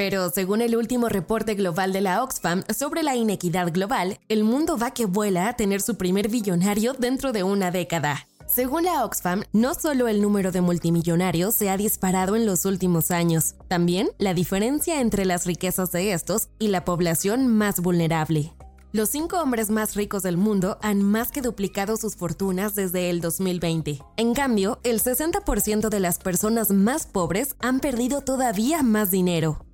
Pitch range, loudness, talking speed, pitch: 180-230 Hz, -23 LUFS, 175 wpm, 200 Hz